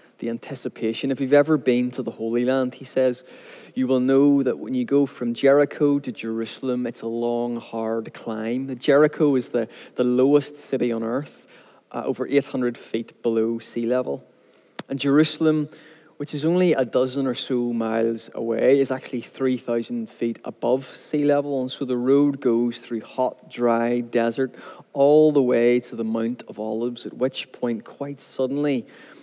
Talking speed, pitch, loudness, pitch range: 170 wpm, 130 Hz, -23 LUFS, 120-140 Hz